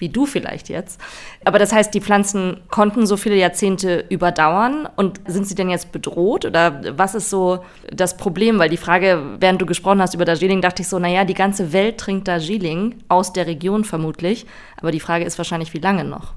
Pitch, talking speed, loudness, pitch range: 185 Hz, 205 wpm, -18 LUFS, 175-200 Hz